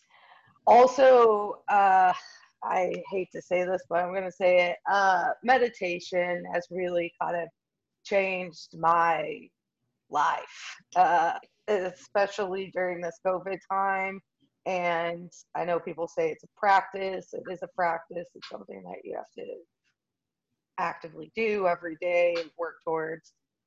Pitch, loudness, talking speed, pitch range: 180 Hz, -27 LUFS, 135 wpm, 170-195 Hz